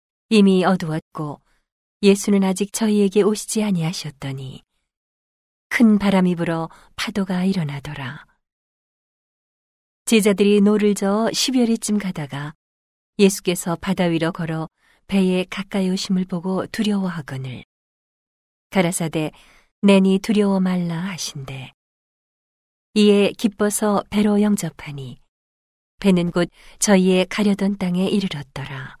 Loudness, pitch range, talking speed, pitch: -19 LUFS, 160-205 Hz, 250 characters per minute, 185 Hz